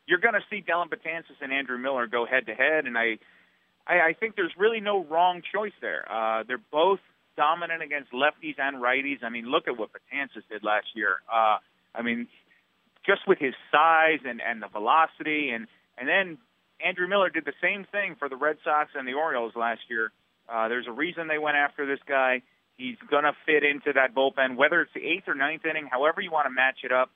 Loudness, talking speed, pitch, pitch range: -26 LUFS, 220 wpm, 145 Hz, 125-165 Hz